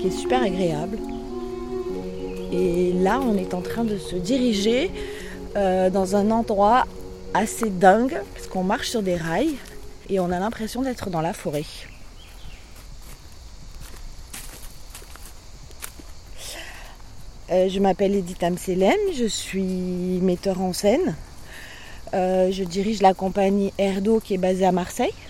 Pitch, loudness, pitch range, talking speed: 185 Hz, -23 LUFS, 165-200 Hz, 130 wpm